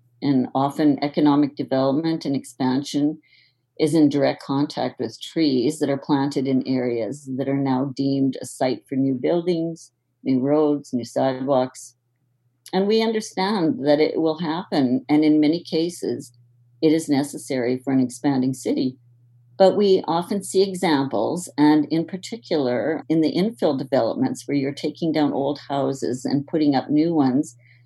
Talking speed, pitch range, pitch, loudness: 155 wpm, 130-160 Hz, 140 Hz, -22 LUFS